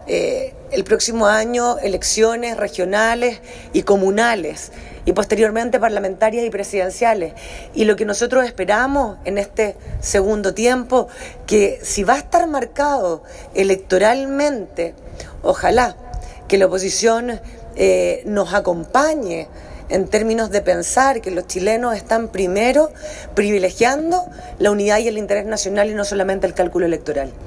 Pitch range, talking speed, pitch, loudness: 195-240 Hz, 125 wpm, 215 Hz, -18 LUFS